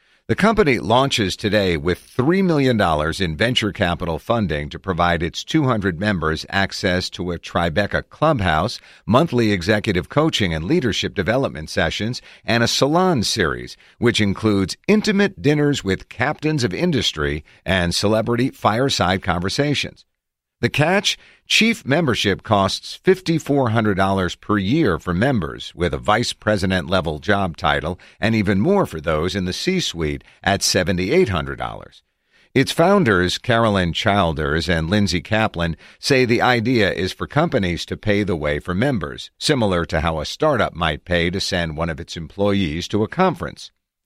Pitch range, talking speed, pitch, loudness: 85-120 Hz, 145 wpm, 100 Hz, -19 LUFS